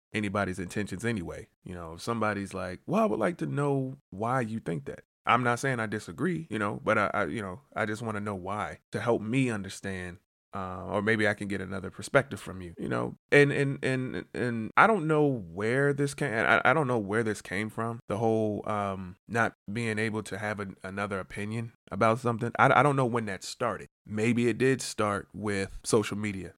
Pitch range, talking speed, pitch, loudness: 95-120 Hz, 220 wpm, 105 Hz, -29 LUFS